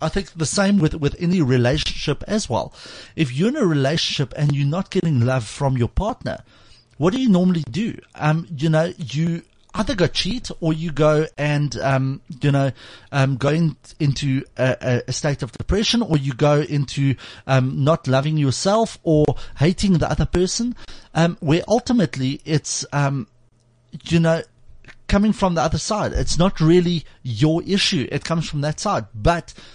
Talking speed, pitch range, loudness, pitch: 175 wpm, 135-170 Hz, -20 LUFS, 155 Hz